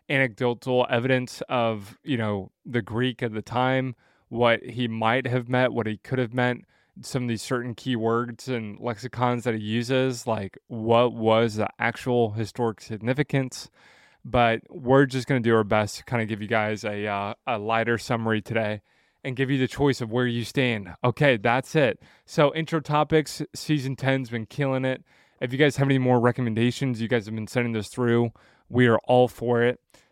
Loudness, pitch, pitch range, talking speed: -25 LUFS, 120 Hz, 115-130 Hz, 190 wpm